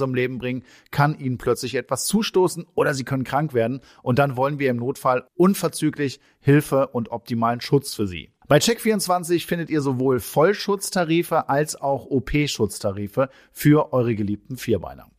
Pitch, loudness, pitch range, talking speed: 135 Hz, -22 LUFS, 125-155 Hz, 155 wpm